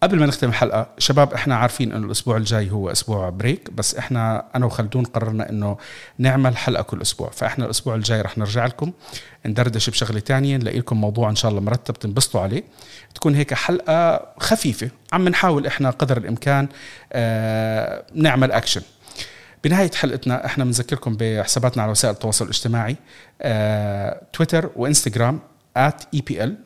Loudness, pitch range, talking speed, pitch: -20 LUFS, 110-140 Hz, 150 wpm, 125 Hz